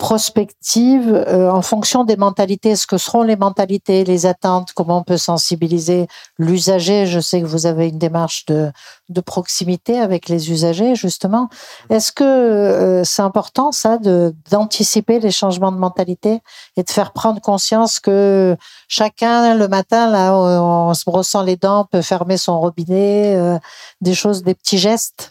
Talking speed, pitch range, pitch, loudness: 165 wpm, 180-215 Hz, 195 Hz, -15 LUFS